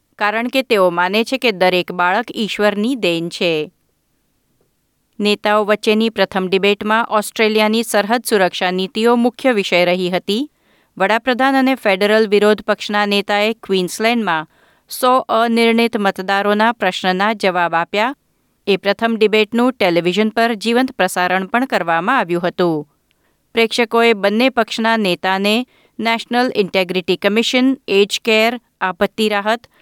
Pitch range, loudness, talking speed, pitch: 190-230 Hz, -16 LUFS, 115 wpm, 210 Hz